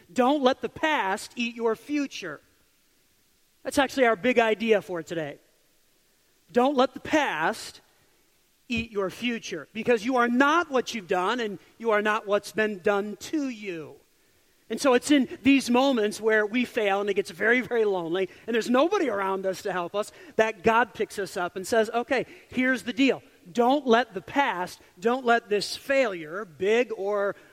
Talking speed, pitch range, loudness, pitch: 175 wpm, 200-255 Hz, -25 LUFS, 230 Hz